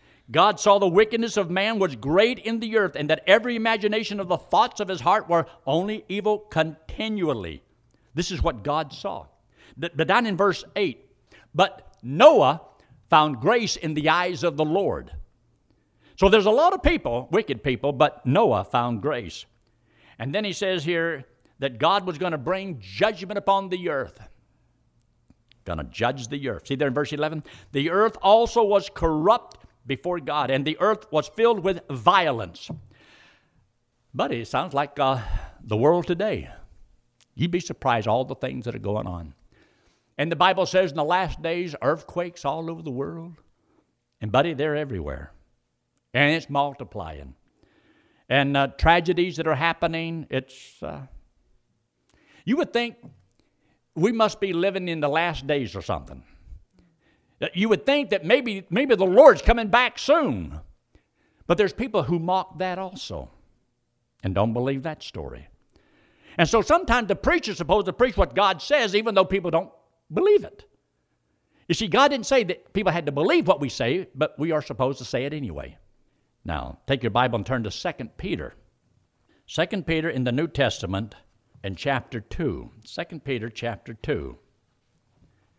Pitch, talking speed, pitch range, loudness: 160 Hz, 170 wpm, 130-195 Hz, -23 LUFS